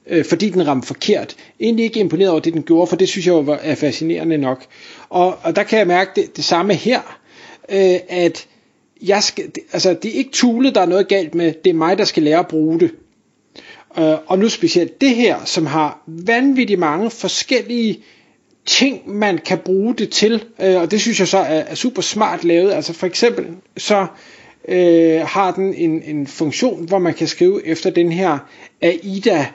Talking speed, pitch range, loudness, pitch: 205 wpm, 165-215 Hz, -16 LUFS, 185 Hz